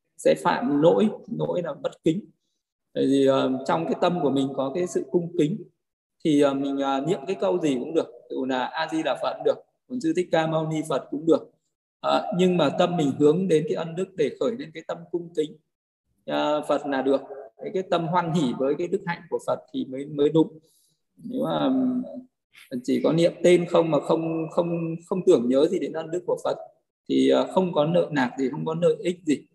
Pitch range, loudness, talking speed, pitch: 140-180 Hz, -24 LUFS, 235 wpm, 165 Hz